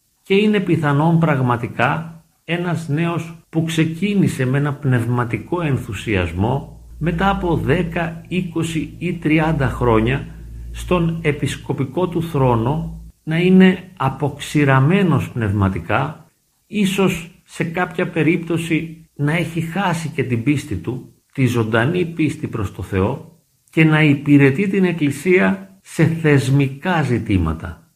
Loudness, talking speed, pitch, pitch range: -18 LUFS, 110 wpm, 155 Hz, 130-170 Hz